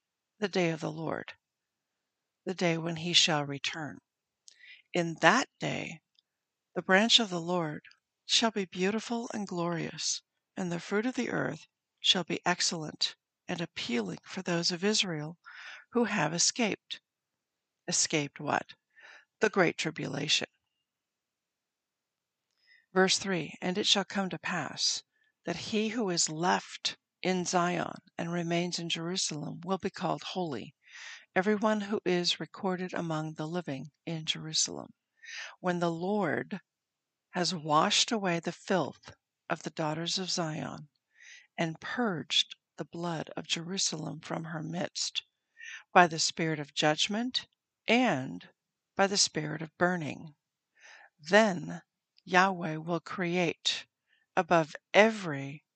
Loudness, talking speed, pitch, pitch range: -30 LUFS, 125 wpm, 175 Hz, 160-195 Hz